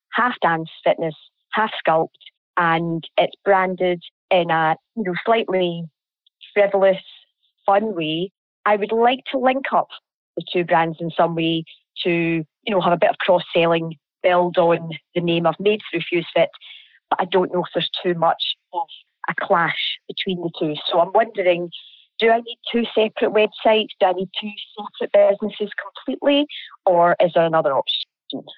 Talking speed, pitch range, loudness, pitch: 165 wpm, 170-210 Hz, -20 LUFS, 180 Hz